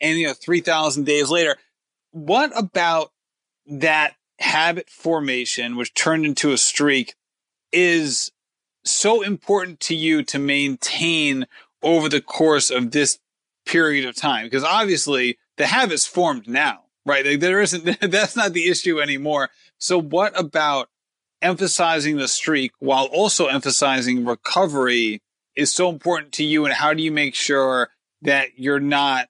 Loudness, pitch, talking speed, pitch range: -19 LUFS, 150 Hz, 145 wpm, 140-170 Hz